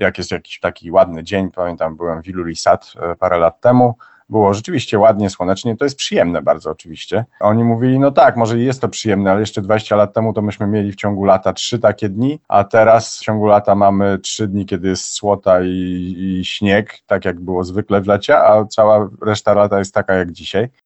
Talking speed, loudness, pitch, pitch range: 205 wpm, -15 LUFS, 105 Hz, 95-110 Hz